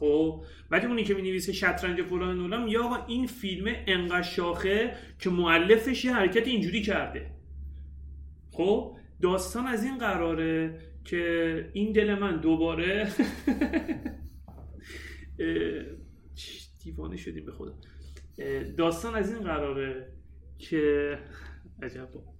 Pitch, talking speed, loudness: 165 Hz, 105 wpm, -28 LUFS